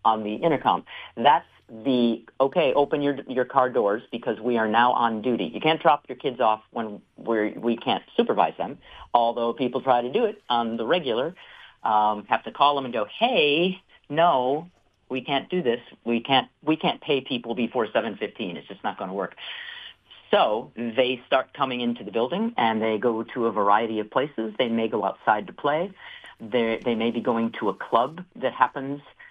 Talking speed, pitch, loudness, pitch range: 195 wpm, 120 Hz, -24 LUFS, 115-135 Hz